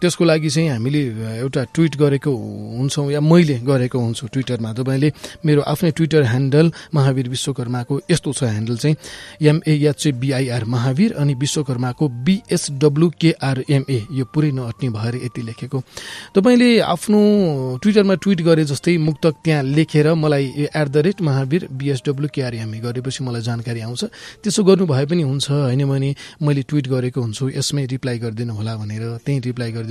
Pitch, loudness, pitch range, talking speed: 140 Hz, -18 LUFS, 125-155 Hz, 155 wpm